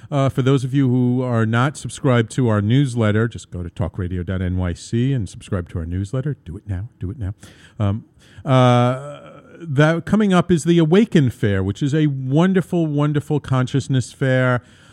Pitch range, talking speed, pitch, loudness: 105-145 Hz, 175 wpm, 125 Hz, -19 LUFS